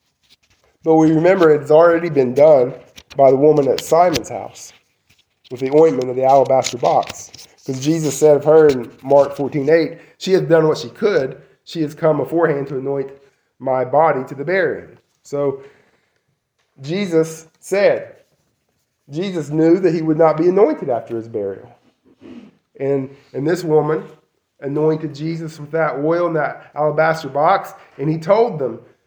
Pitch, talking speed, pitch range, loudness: 150 Hz, 155 wpm, 135-160 Hz, -16 LUFS